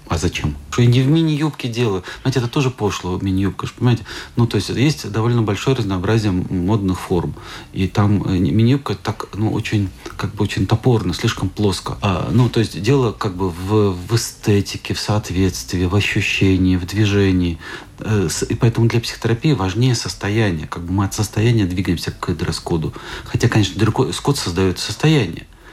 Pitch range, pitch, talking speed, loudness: 95-120 Hz, 105 Hz, 160 wpm, -18 LUFS